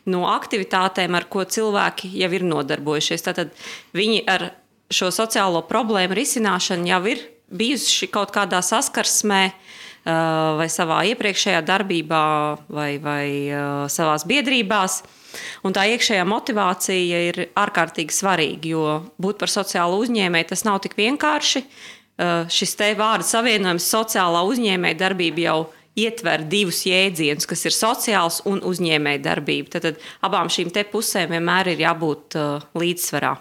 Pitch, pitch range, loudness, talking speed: 185 Hz, 165-210 Hz, -20 LUFS, 130 wpm